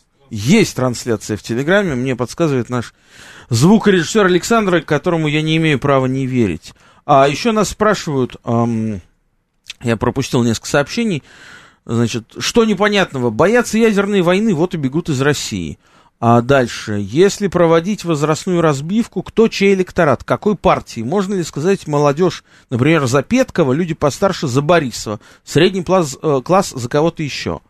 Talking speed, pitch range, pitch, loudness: 140 wpm, 125-190 Hz, 155 Hz, -15 LUFS